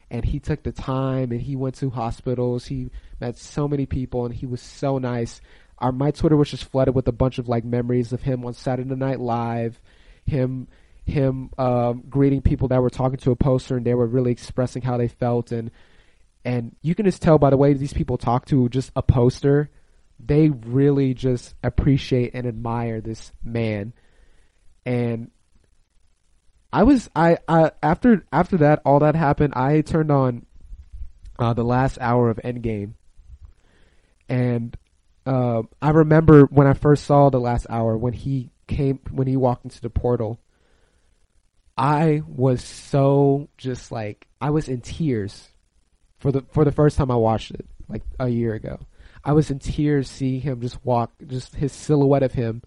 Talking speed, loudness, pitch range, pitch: 180 wpm, -21 LUFS, 115-140 Hz, 125 Hz